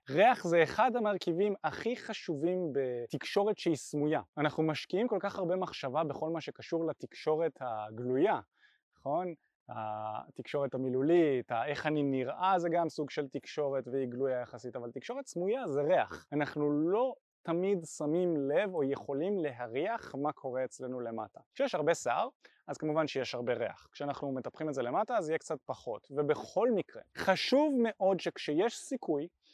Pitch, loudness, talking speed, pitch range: 150 Hz, -33 LUFS, 150 wpm, 135-180 Hz